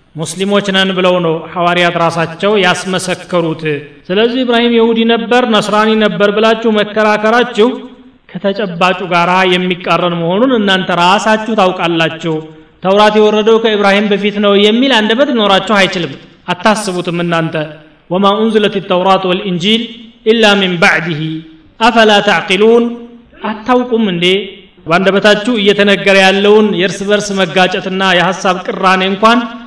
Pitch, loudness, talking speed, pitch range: 195 Hz, -10 LUFS, 110 wpm, 180-220 Hz